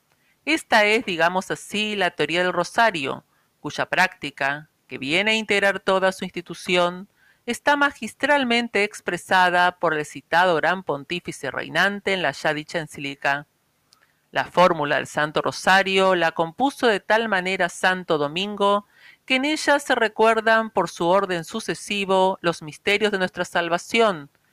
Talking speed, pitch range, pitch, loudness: 140 wpm, 170-210 Hz, 185 Hz, -21 LUFS